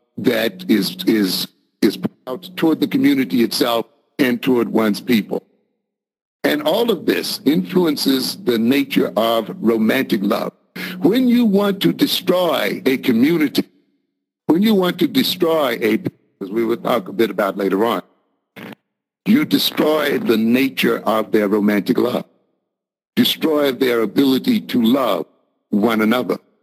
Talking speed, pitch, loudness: 135 wpm, 155 Hz, -17 LUFS